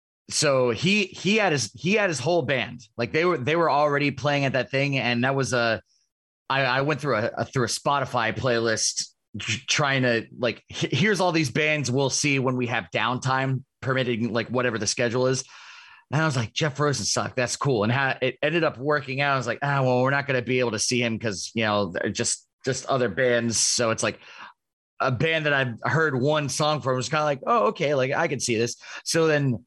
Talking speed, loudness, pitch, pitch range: 235 wpm, -24 LUFS, 130 Hz, 120-150 Hz